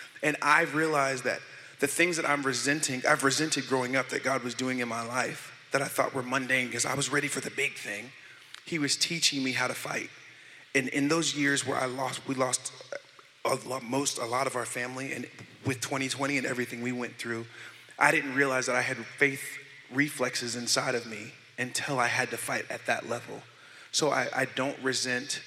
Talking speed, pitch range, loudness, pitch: 200 wpm, 125-140 Hz, -29 LUFS, 130 Hz